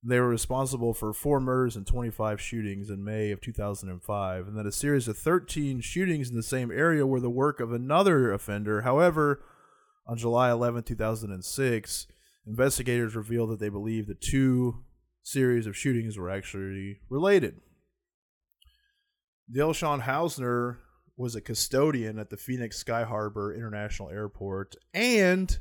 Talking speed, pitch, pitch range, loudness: 145 wpm, 120 Hz, 105-135 Hz, -28 LUFS